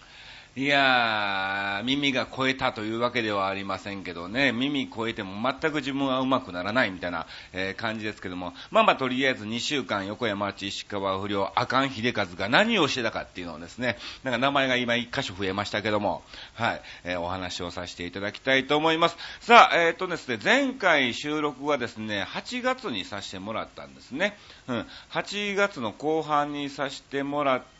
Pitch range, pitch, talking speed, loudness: 100-145 Hz, 120 Hz, 370 characters per minute, -26 LUFS